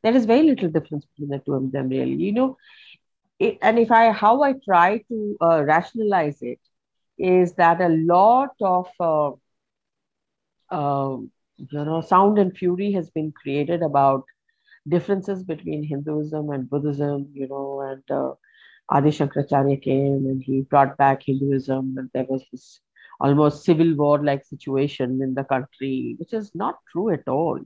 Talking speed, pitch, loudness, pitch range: 165 wpm, 150 Hz, -21 LUFS, 140-185 Hz